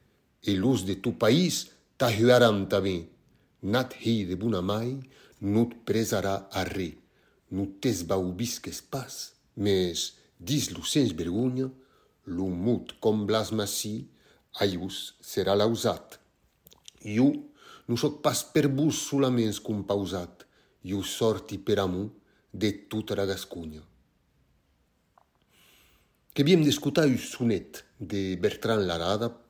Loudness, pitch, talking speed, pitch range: -28 LUFS, 105 Hz, 100 wpm, 95-120 Hz